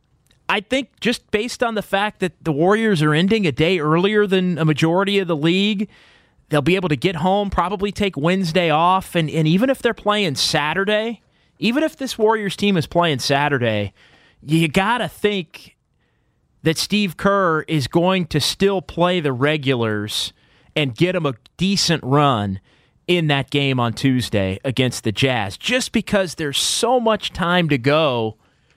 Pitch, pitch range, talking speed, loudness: 170 Hz, 145-200 Hz, 170 wpm, -19 LUFS